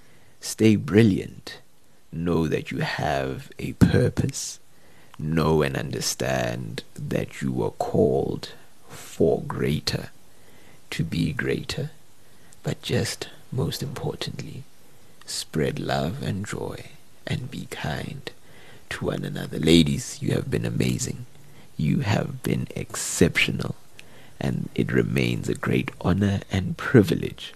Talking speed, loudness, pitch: 110 wpm, -25 LUFS, 85 Hz